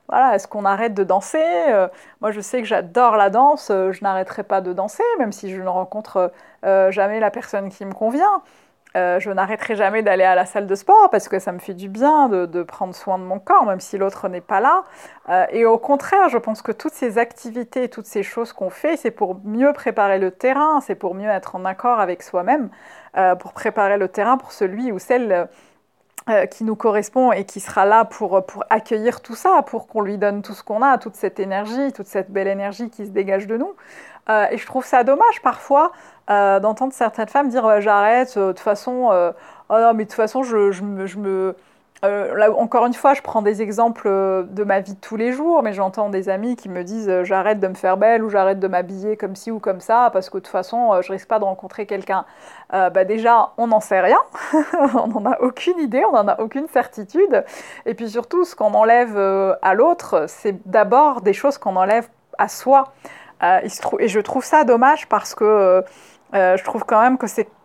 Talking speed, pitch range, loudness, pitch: 225 wpm, 195-245 Hz, -18 LUFS, 215 Hz